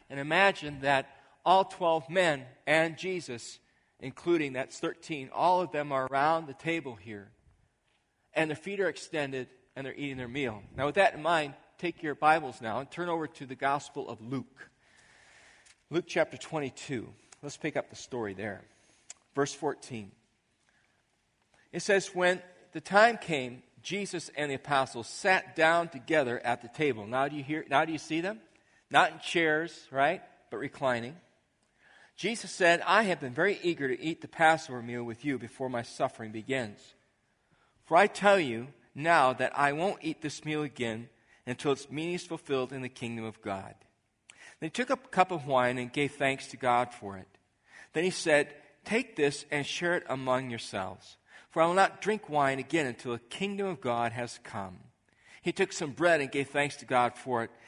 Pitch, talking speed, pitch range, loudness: 145 Hz, 185 wpm, 125-165 Hz, -30 LUFS